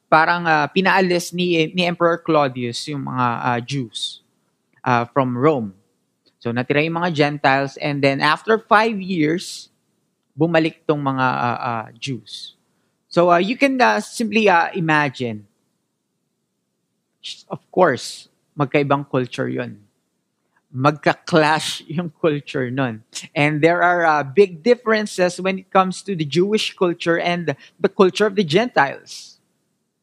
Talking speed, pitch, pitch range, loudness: 130 wpm, 160 Hz, 140-180 Hz, -19 LUFS